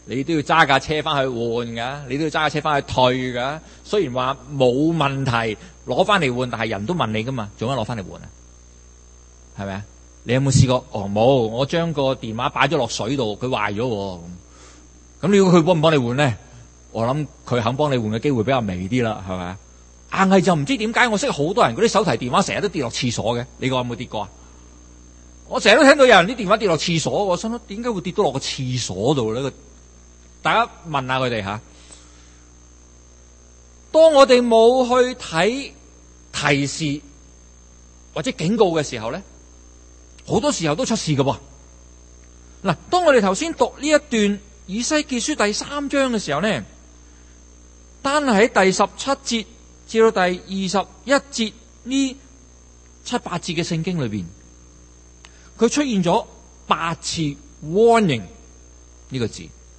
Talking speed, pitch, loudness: 250 characters per minute, 130 Hz, -19 LUFS